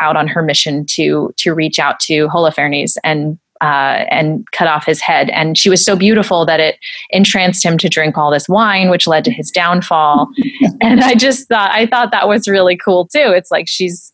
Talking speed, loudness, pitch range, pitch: 210 wpm, -11 LUFS, 155-200 Hz, 175 Hz